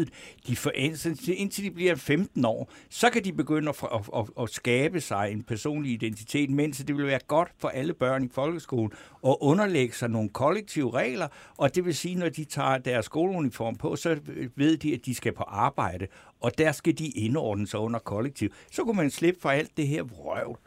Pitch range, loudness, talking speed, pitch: 120-160 Hz, -28 LUFS, 195 wpm, 145 Hz